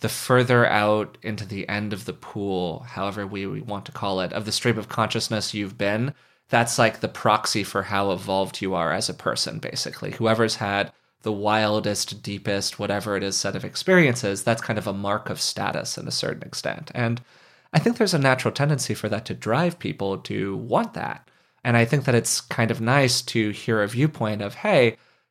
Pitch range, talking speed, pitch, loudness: 100-120 Hz, 205 wpm, 105 Hz, -24 LUFS